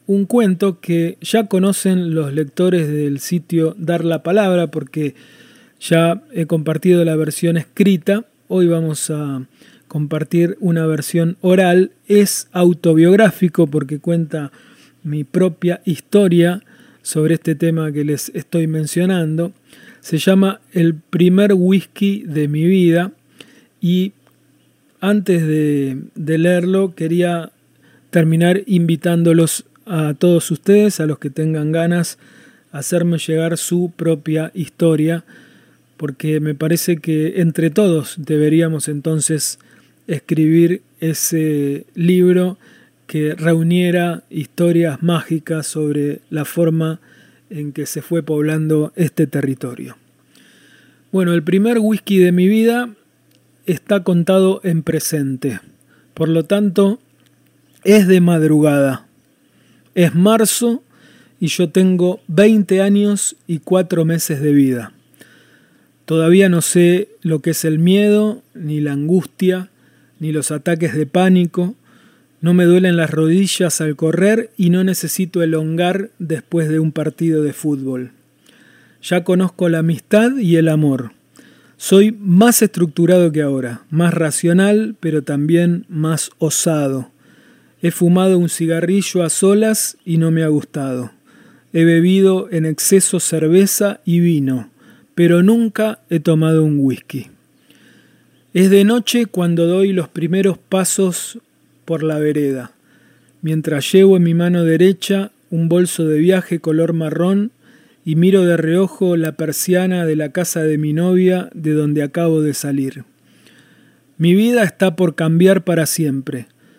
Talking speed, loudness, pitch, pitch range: 125 wpm, -15 LUFS, 170 Hz, 155-185 Hz